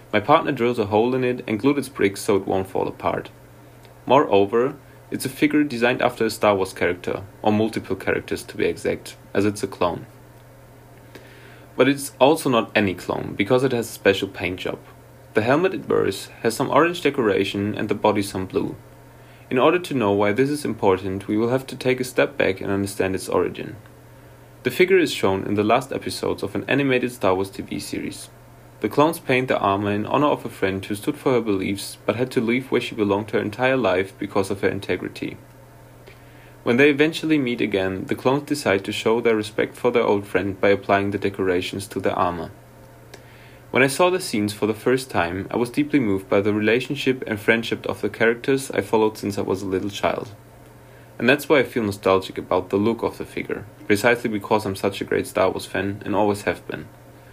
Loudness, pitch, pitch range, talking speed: -22 LUFS, 115 Hz, 100-130 Hz, 210 wpm